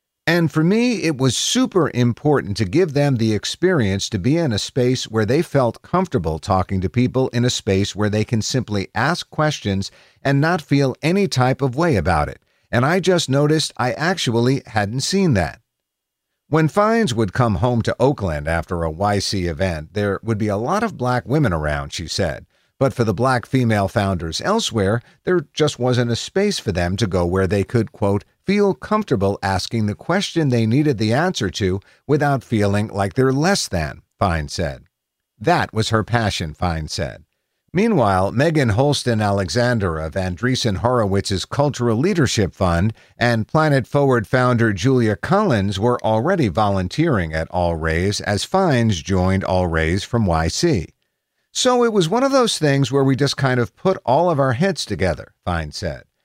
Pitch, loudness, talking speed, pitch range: 120 Hz, -19 LUFS, 175 wpm, 100-145 Hz